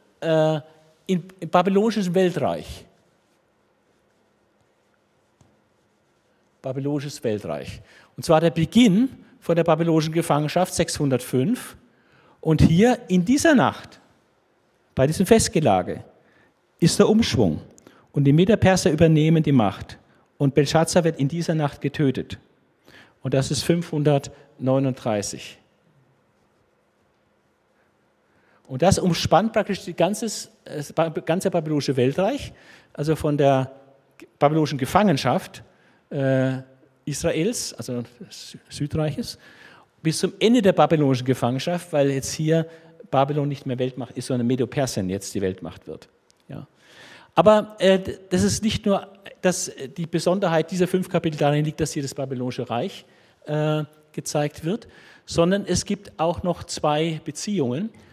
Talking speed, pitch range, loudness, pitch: 110 wpm, 135-180 Hz, -22 LUFS, 155 Hz